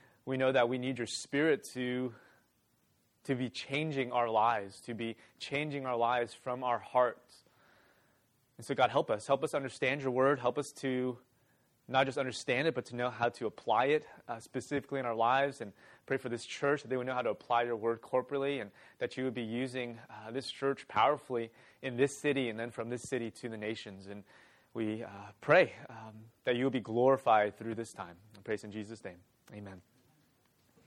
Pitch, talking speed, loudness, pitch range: 125 Hz, 200 wpm, -34 LUFS, 115-135 Hz